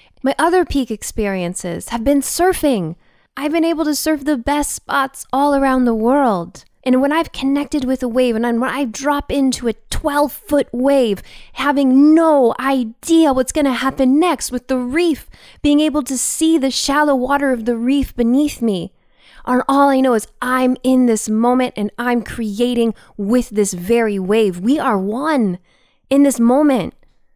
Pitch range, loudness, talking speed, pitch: 235-285 Hz, -16 LUFS, 175 wpm, 260 Hz